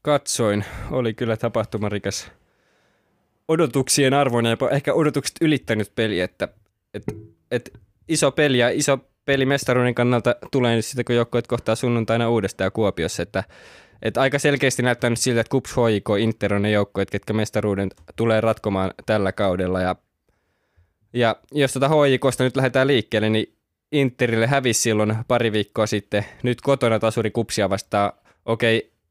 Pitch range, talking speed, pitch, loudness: 105-130 Hz, 150 wpm, 115 Hz, -21 LUFS